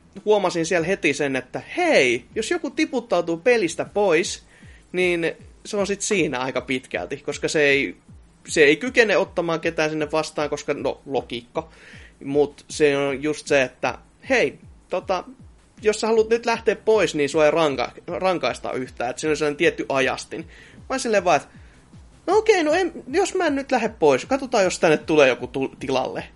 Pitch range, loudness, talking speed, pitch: 150-245 Hz, -22 LUFS, 175 wpm, 180 Hz